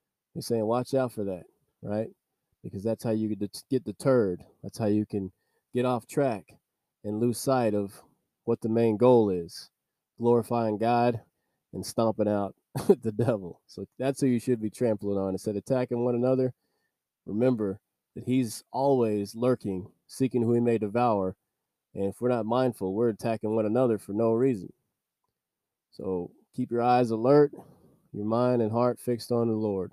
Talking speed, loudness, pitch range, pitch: 170 wpm, -28 LUFS, 105-125 Hz, 115 Hz